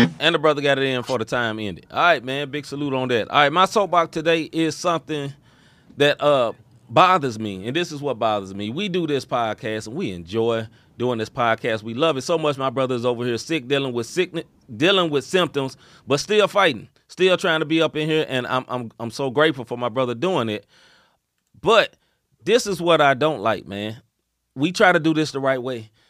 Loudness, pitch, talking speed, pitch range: -21 LUFS, 140 Hz, 225 wpm, 120-160 Hz